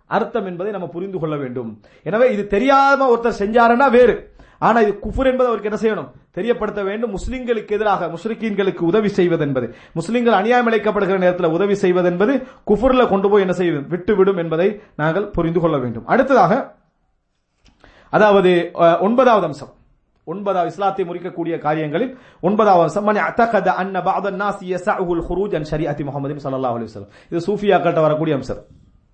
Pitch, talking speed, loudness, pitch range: 190 Hz, 120 wpm, -18 LUFS, 165-215 Hz